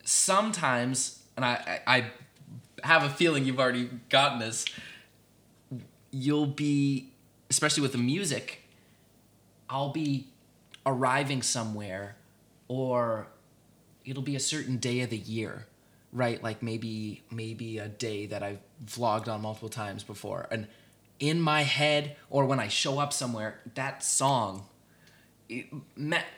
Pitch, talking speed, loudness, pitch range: 125 Hz, 130 wpm, -29 LUFS, 110-140 Hz